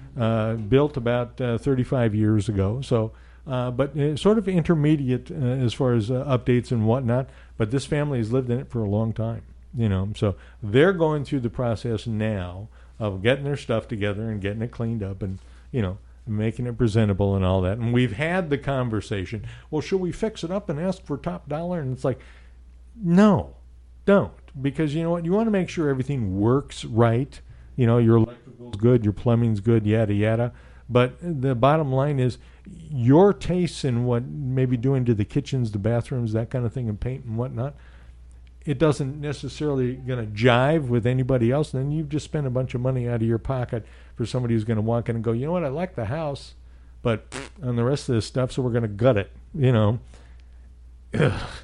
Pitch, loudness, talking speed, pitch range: 120 Hz, -24 LUFS, 210 wpm, 110-140 Hz